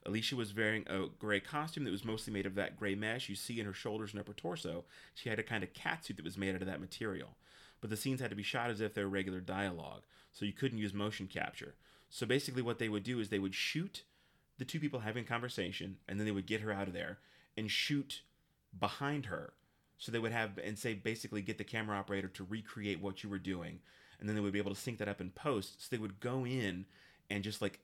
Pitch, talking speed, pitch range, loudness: 105 Hz, 255 wpm, 95-115 Hz, -40 LUFS